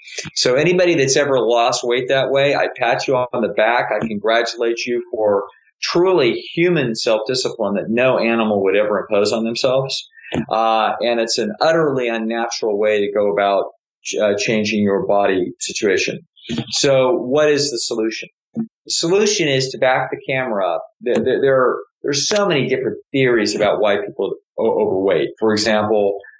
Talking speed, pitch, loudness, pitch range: 170 wpm, 120 Hz, -17 LUFS, 110-145 Hz